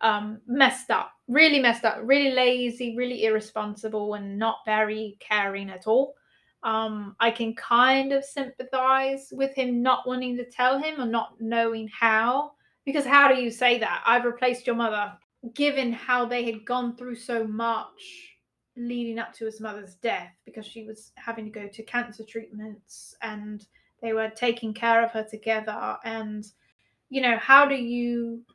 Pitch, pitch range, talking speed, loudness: 230 Hz, 220-255 Hz, 170 wpm, -24 LUFS